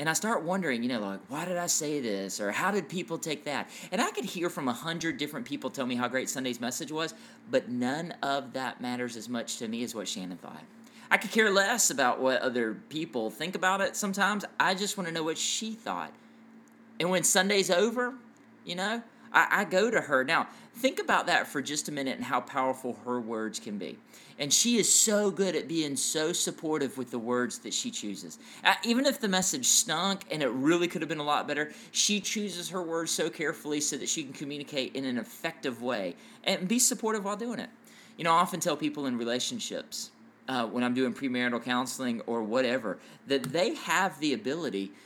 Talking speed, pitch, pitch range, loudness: 215 wpm, 165 Hz, 130-215 Hz, -29 LUFS